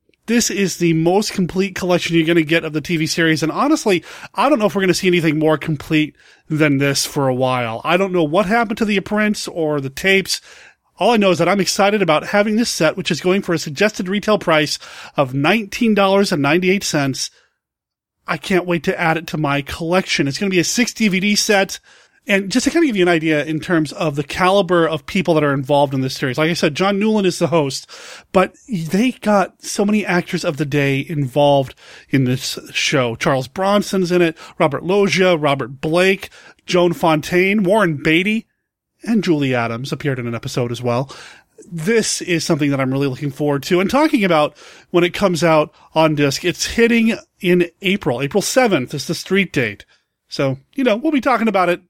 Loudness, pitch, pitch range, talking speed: -17 LUFS, 175 Hz, 150-195 Hz, 210 wpm